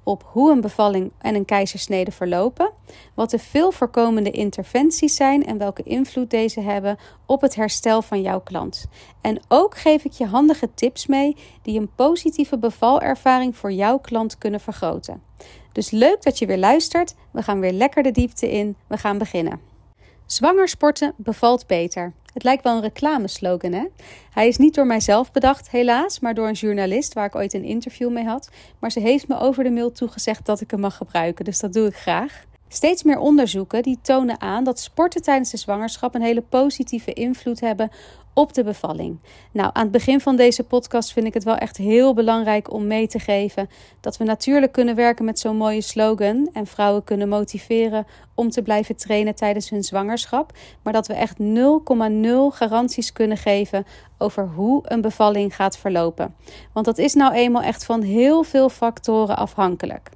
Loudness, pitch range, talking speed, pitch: -20 LUFS, 205-255 Hz, 185 wpm, 225 Hz